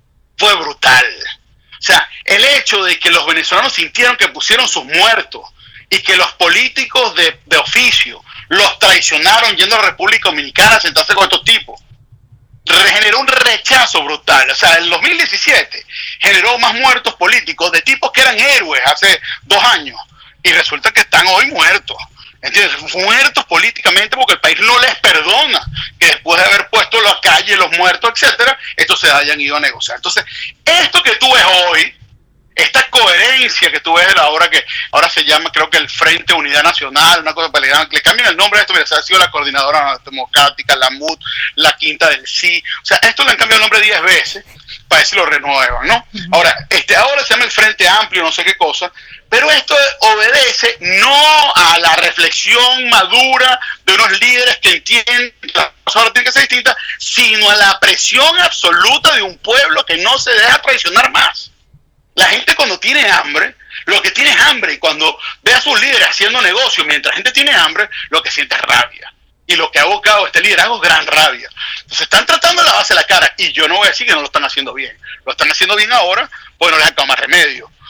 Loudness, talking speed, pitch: -9 LUFS, 200 wpm, 235 Hz